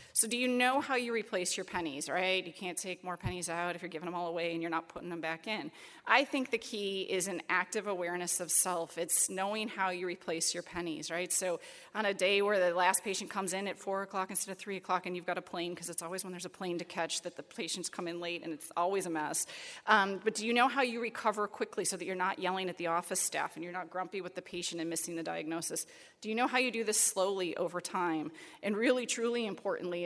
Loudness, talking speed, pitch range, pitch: -33 LUFS, 265 wpm, 175-205 Hz, 185 Hz